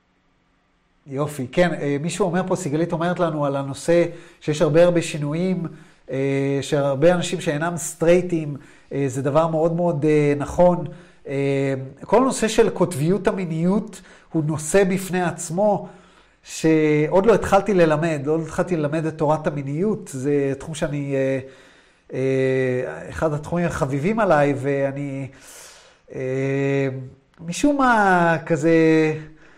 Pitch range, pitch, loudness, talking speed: 140-175 Hz, 160 Hz, -21 LUFS, 110 wpm